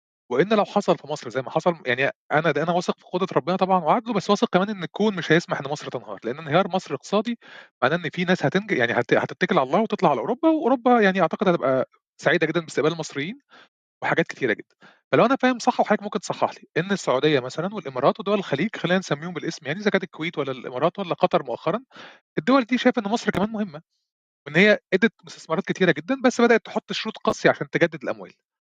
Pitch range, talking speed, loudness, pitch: 155-210 Hz, 215 wpm, -23 LUFS, 180 Hz